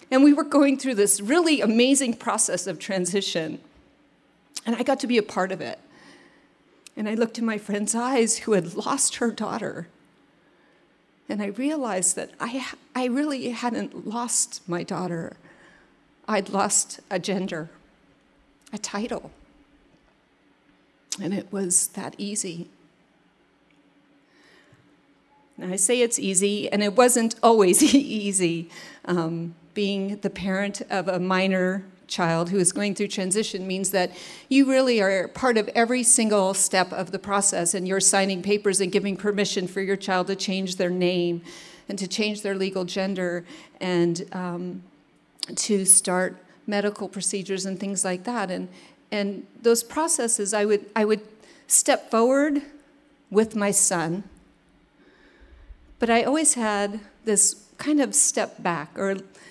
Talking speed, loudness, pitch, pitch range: 145 wpm, -23 LUFS, 200 Hz, 190-235 Hz